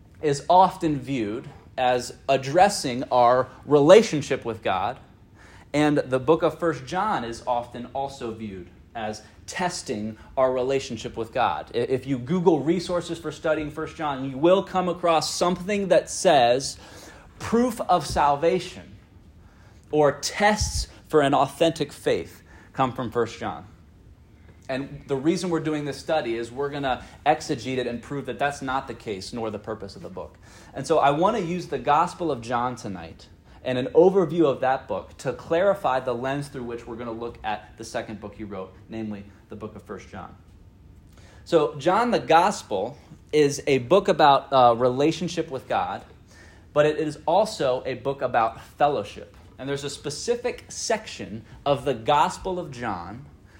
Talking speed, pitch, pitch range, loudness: 165 wpm, 130 Hz, 110-155 Hz, -24 LUFS